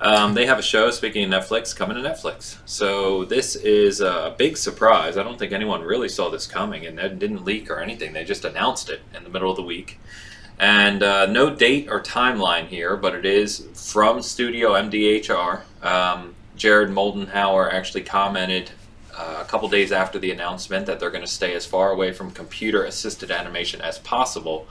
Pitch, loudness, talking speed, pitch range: 100 Hz, -21 LUFS, 195 wpm, 95-105 Hz